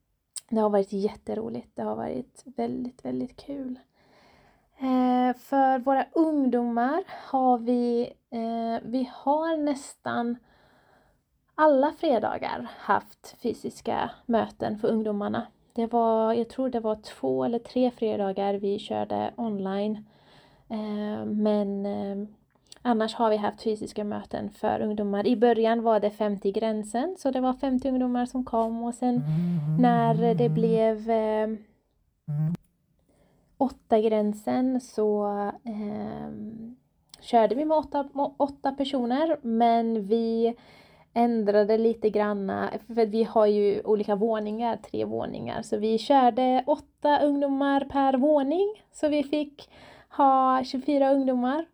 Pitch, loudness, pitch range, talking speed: 230 Hz, -26 LUFS, 210-260 Hz, 120 wpm